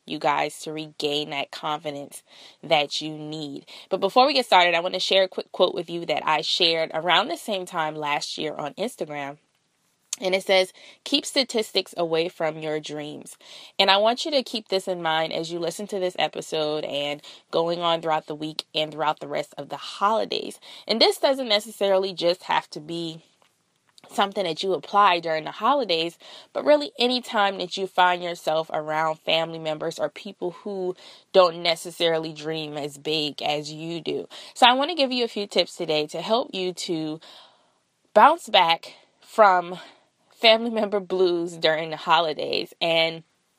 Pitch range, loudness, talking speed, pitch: 155-195 Hz, -23 LUFS, 180 wpm, 170 Hz